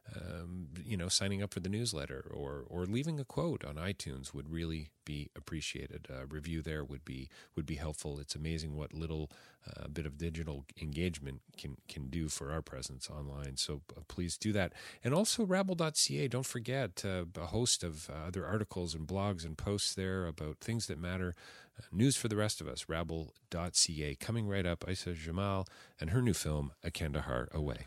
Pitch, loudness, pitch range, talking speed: 85 Hz, -37 LUFS, 75-100 Hz, 190 wpm